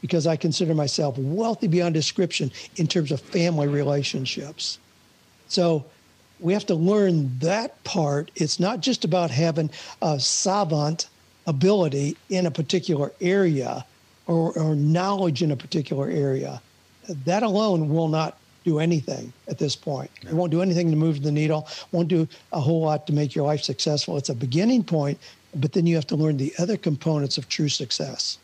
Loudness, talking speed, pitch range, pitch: -24 LUFS, 170 wpm, 145-175 Hz, 160 Hz